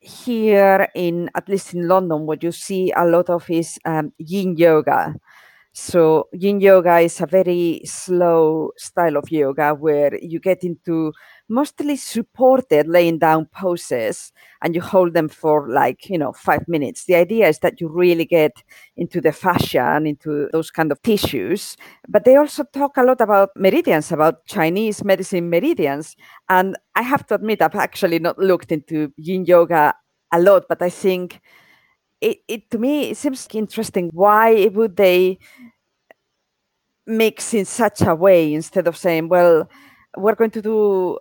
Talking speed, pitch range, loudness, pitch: 165 wpm, 165-210 Hz, -17 LUFS, 180 Hz